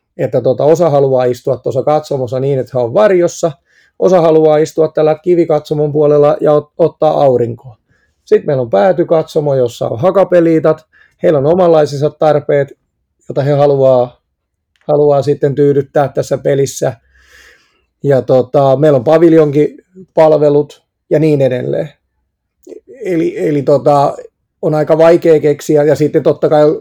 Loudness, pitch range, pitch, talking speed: -11 LUFS, 140-160 Hz, 150 Hz, 135 wpm